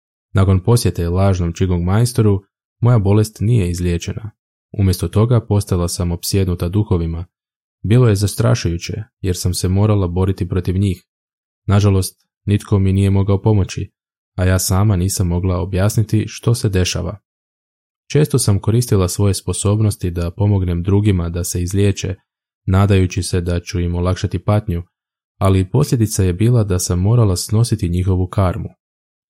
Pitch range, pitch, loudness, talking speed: 90-105 Hz, 95 Hz, -17 LUFS, 140 wpm